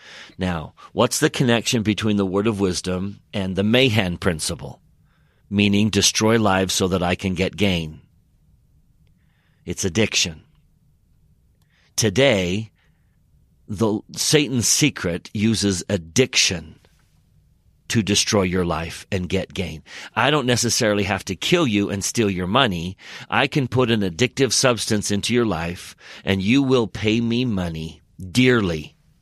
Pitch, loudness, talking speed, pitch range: 100 Hz, -20 LUFS, 130 wpm, 90-115 Hz